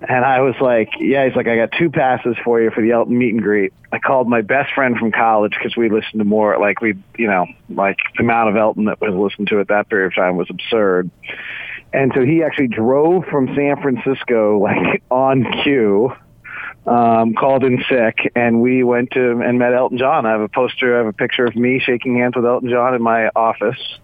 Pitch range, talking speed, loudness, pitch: 115-130 Hz, 230 wpm, -16 LUFS, 120 Hz